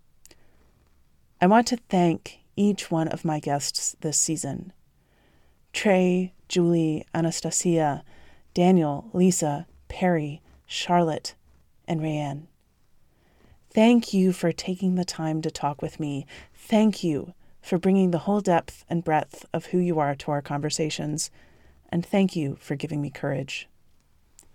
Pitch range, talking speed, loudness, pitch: 145-180 Hz, 130 wpm, -25 LUFS, 160 Hz